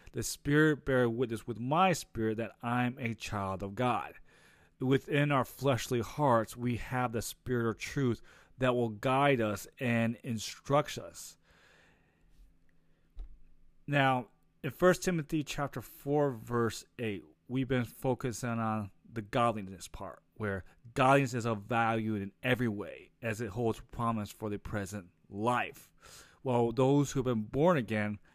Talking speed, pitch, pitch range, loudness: 145 wpm, 120 Hz, 105-130 Hz, -32 LUFS